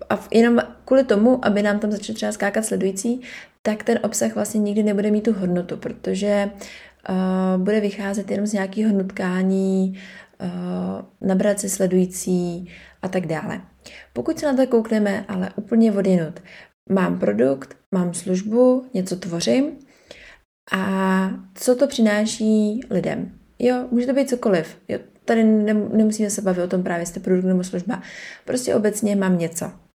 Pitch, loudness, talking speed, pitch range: 205 Hz, -21 LUFS, 150 wpm, 185-220 Hz